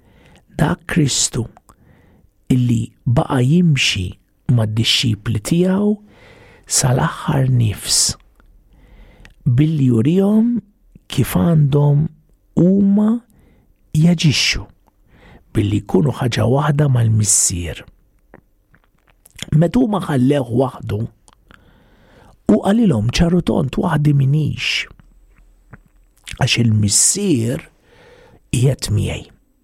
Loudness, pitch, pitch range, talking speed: -16 LUFS, 135 Hz, 110-170 Hz, 75 wpm